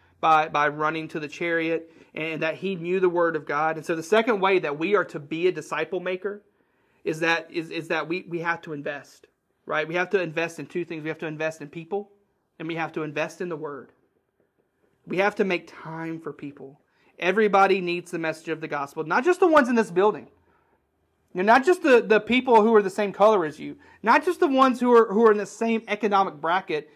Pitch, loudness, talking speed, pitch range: 175 Hz, -23 LUFS, 235 wpm, 160-210 Hz